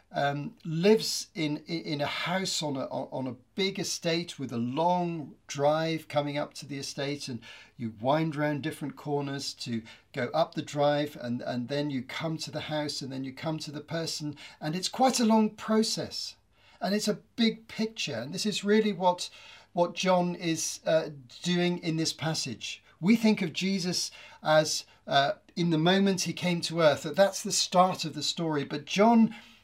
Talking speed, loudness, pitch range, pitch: 190 wpm, -29 LUFS, 145-180 Hz, 160 Hz